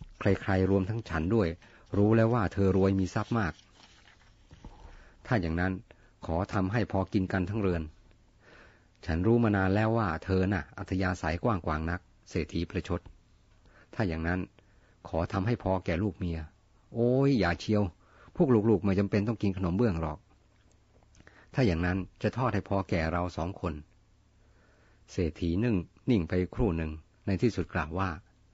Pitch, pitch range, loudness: 95 Hz, 90-105 Hz, -30 LUFS